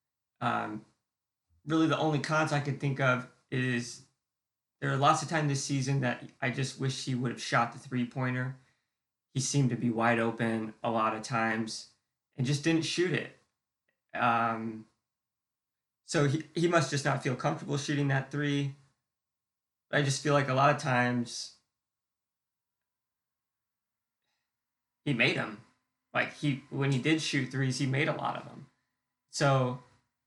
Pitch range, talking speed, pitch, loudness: 120-145 Hz, 160 wpm, 130 Hz, -30 LUFS